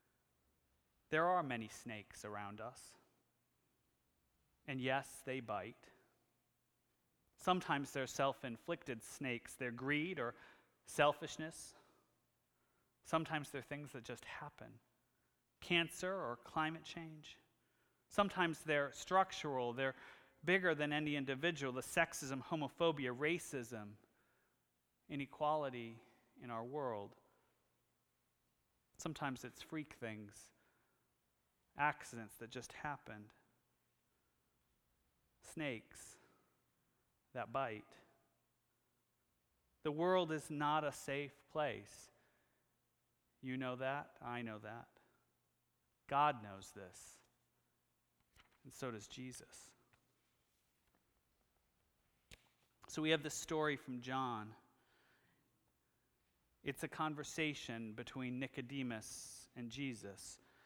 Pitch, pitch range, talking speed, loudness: 130 Hz, 100-150 Hz, 90 wpm, -42 LUFS